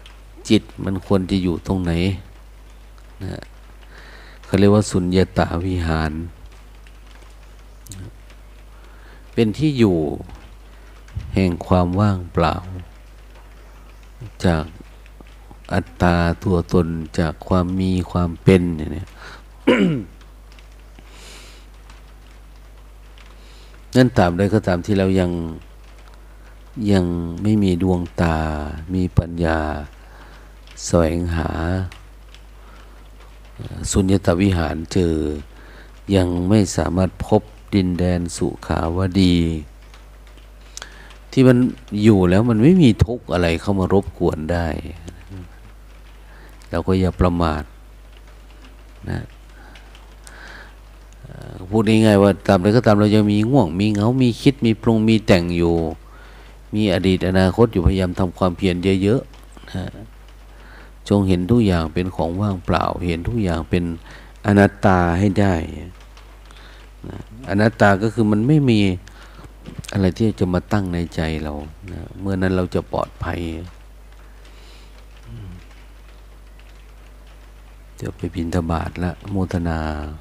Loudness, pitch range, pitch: -19 LUFS, 85-105 Hz, 95 Hz